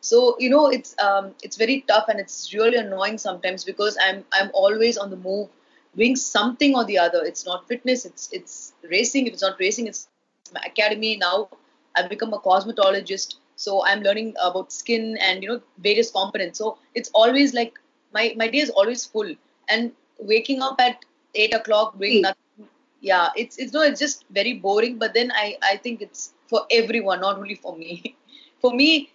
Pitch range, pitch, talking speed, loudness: 195-250 Hz, 220 Hz, 195 wpm, -21 LUFS